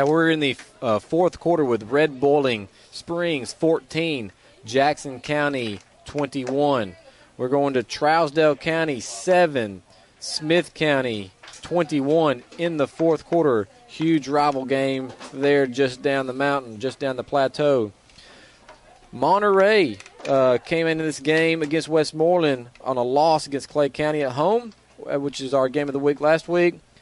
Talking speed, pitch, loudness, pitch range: 140 wpm, 145 Hz, -22 LUFS, 130-160 Hz